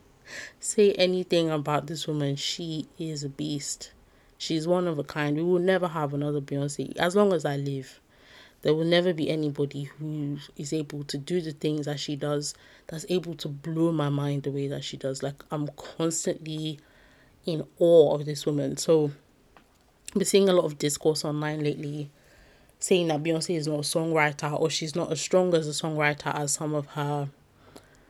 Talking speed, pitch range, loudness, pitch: 185 wpm, 145-165 Hz, -27 LUFS, 150 Hz